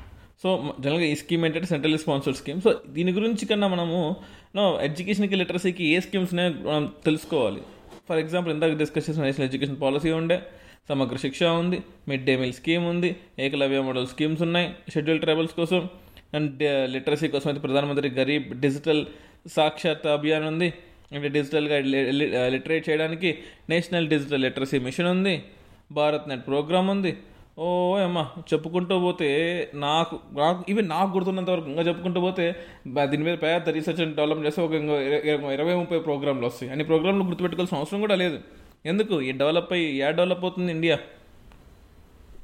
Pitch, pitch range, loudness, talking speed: 160 Hz, 145-175 Hz, -25 LUFS, 150 wpm